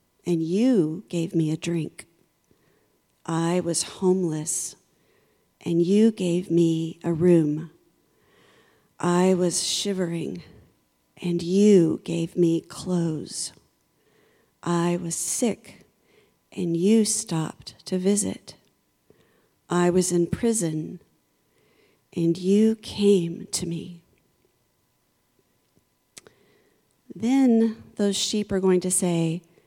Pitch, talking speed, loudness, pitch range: 175 Hz, 95 wpm, -24 LUFS, 170-195 Hz